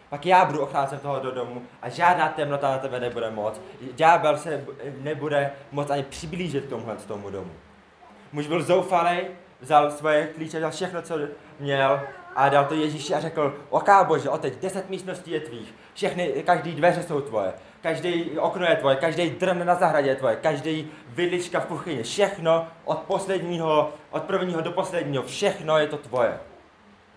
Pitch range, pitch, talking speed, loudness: 140-175 Hz, 155 Hz, 170 wpm, -24 LUFS